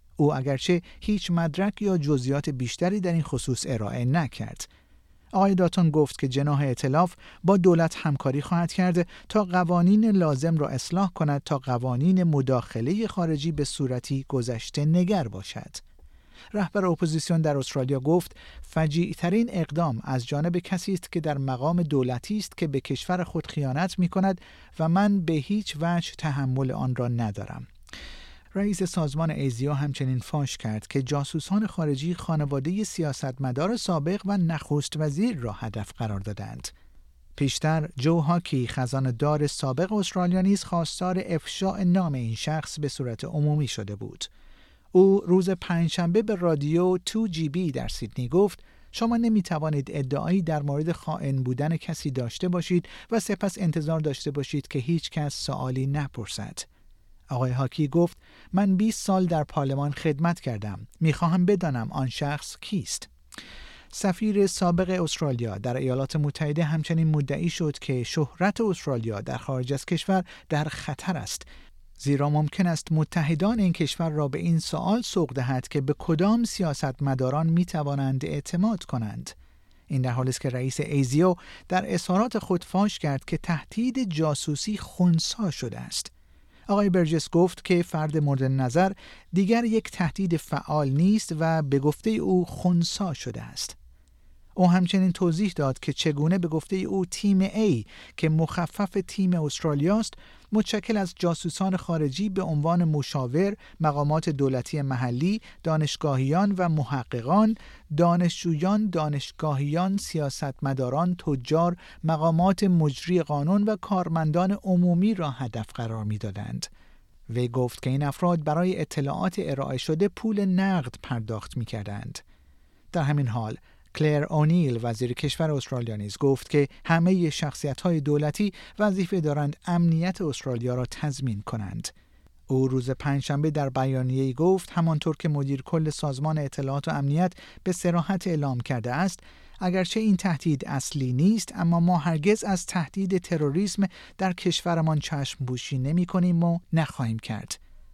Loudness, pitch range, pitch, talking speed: -26 LUFS, 135-180 Hz, 155 Hz, 140 wpm